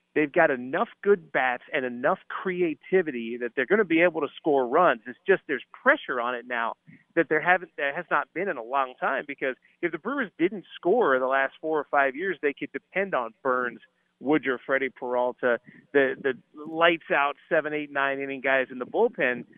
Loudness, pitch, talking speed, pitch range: -26 LUFS, 145 Hz, 205 wpm, 135-175 Hz